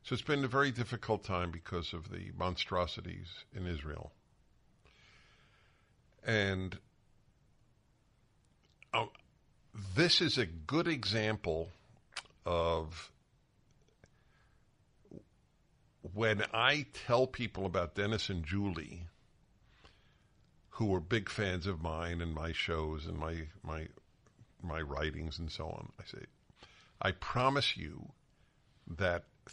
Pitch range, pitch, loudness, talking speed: 85-115 Hz, 100 Hz, -35 LUFS, 105 wpm